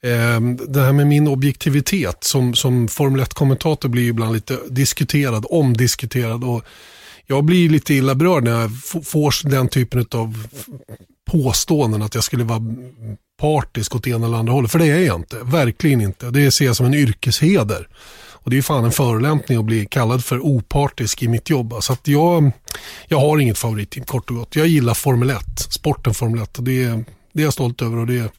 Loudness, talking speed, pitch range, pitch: -17 LUFS, 190 wpm, 115-145 Hz, 125 Hz